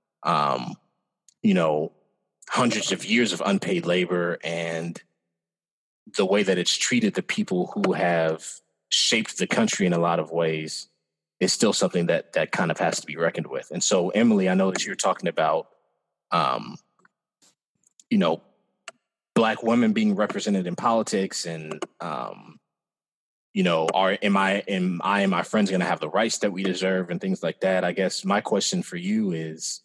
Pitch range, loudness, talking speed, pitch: 85-115 Hz, -24 LUFS, 175 wpm, 95 Hz